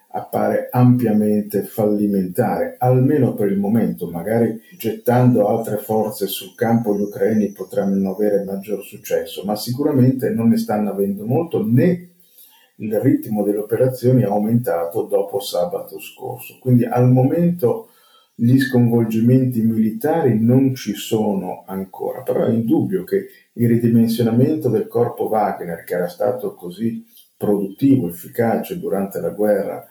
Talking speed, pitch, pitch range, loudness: 130 wpm, 115 Hz, 105-130 Hz, -19 LUFS